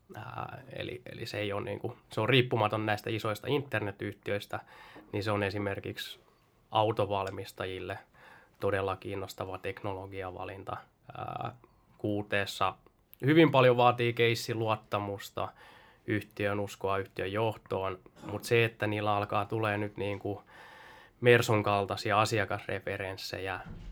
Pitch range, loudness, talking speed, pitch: 100-115 Hz, -31 LUFS, 110 wpm, 105 Hz